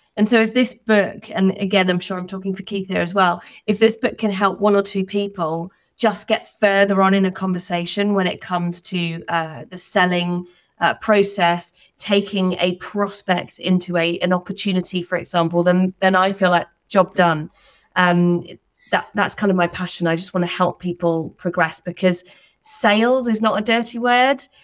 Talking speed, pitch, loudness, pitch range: 190 wpm, 185 Hz, -19 LUFS, 175-205 Hz